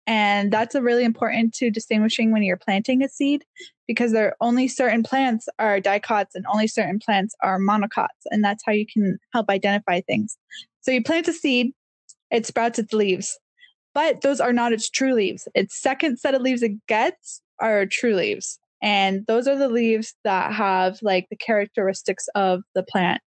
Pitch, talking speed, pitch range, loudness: 225 Hz, 190 wpm, 205-260 Hz, -22 LUFS